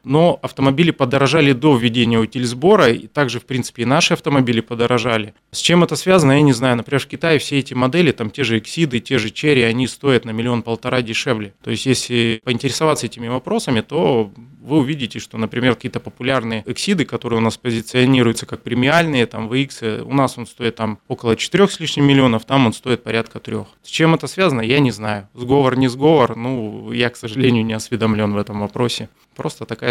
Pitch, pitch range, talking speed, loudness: 125 Hz, 115-140 Hz, 195 wpm, -17 LUFS